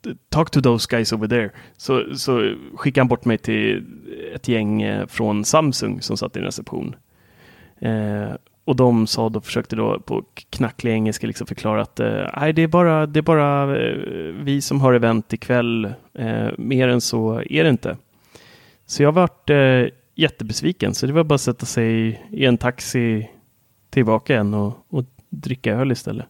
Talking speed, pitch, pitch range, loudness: 175 wpm, 120 Hz, 110-140 Hz, -20 LUFS